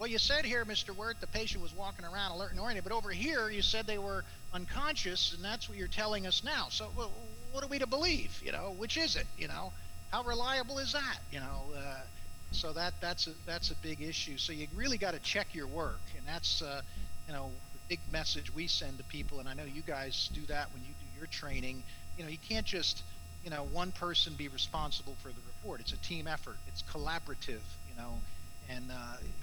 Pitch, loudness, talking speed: 125 Hz, -37 LUFS, 230 wpm